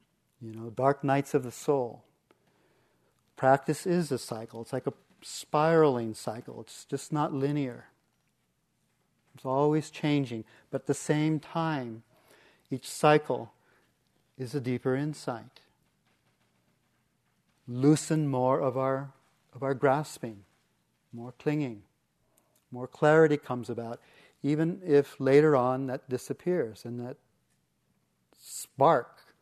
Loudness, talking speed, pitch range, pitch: -29 LUFS, 115 wpm, 125-150 Hz, 135 Hz